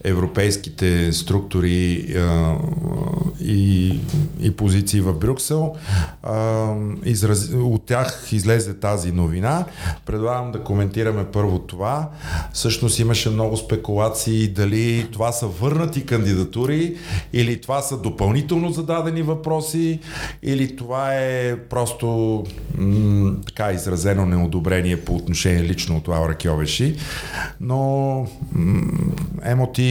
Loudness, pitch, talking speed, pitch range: -21 LUFS, 110 Hz, 100 wpm, 95-135 Hz